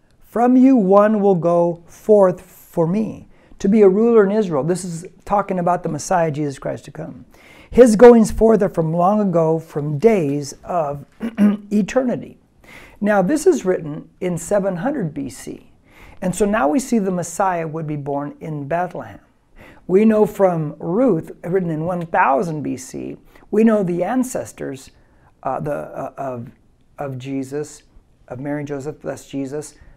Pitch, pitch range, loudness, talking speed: 180 Hz, 150-210 Hz, -18 LUFS, 155 wpm